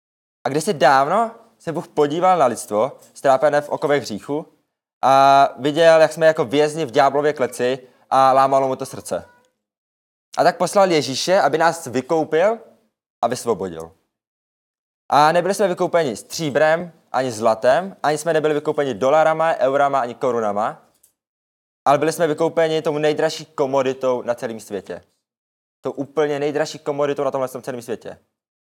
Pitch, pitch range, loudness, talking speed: 150 Hz, 130-160 Hz, -19 LUFS, 145 wpm